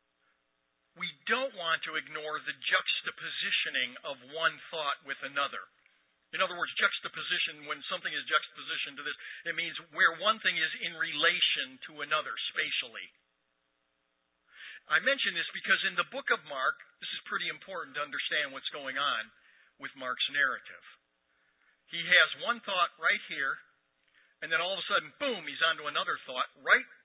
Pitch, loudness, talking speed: 150 Hz, -31 LUFS, 160 wpm